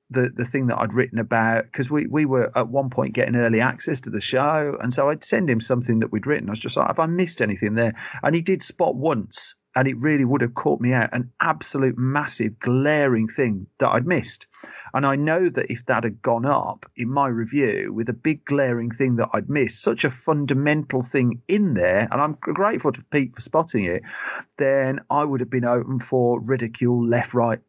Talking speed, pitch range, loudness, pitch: 225 wpm, 120-145 Hz, -22 LUFS, 130 Hz